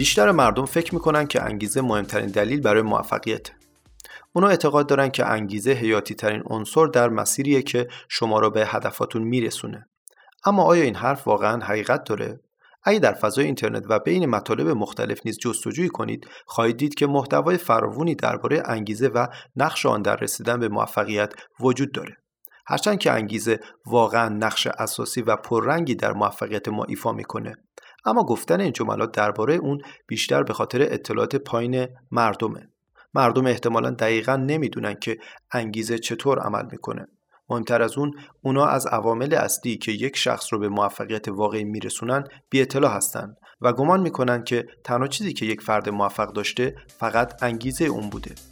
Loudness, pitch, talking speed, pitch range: -23 LUFS, 120 Hz, 155 wpm, 110-135 Hz